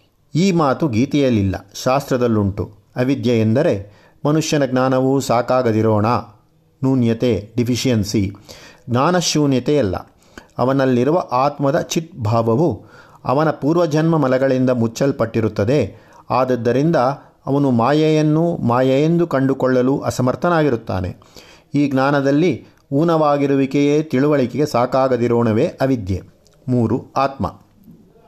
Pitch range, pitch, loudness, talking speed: 115-145 Hz, 130 Hz, -17 LUFS, 70 wpm